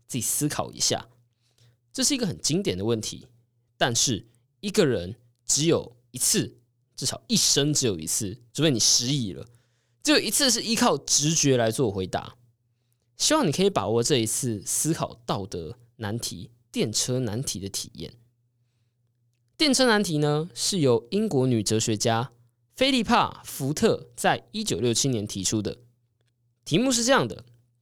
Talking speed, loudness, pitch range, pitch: 235 characters per minute, -24 LUFS, 115-150 Hz, 120 Hz